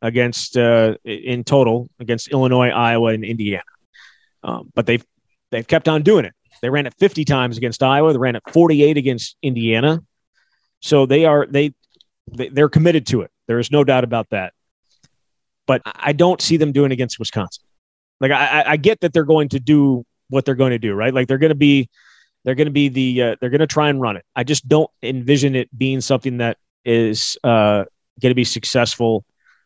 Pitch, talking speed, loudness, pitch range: 130 Hz, 200 wpm, -17 LUFS, 120-145 Hz